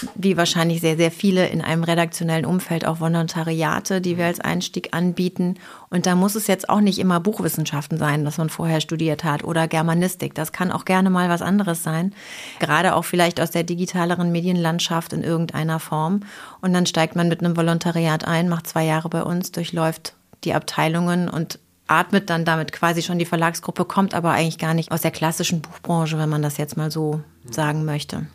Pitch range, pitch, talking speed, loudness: 160-180 Hz, 165 Hz, 195 wpm, -21 LUFS